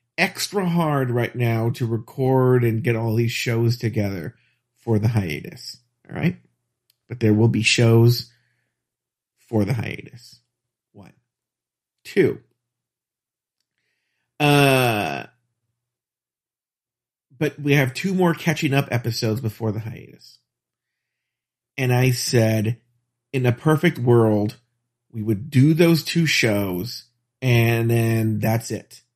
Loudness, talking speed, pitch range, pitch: -20 LUFS, 115 wpm, 115-130 Hz, 120 Hz